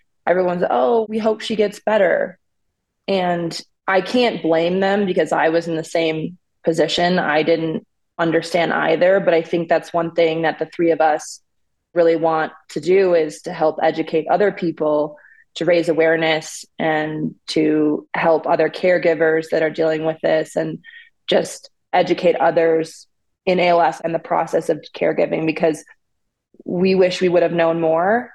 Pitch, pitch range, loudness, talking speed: 165 Hz, 160-180 Hz, -18 LUFS, 160 wpm